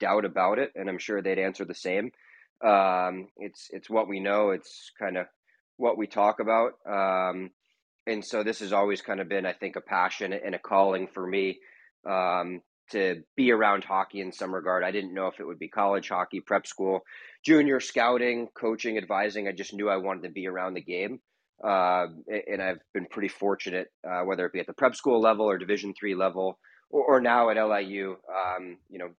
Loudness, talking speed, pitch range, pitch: -28 LUFS, 210 wpm, 95-105 Hz, 95 Hz